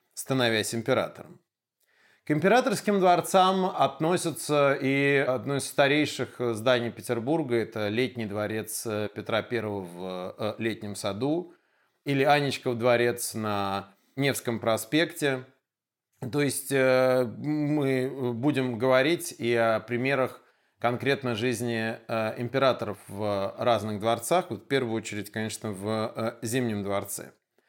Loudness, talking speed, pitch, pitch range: -27 LUFS, 100 wpm, 125 Hz, 110-140 Hz